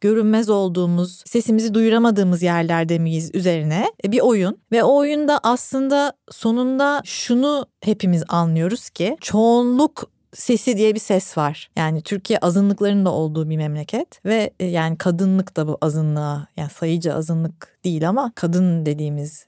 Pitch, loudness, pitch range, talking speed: 185 Hz, -19 LUFS, 165-225 Hz, 135 wpm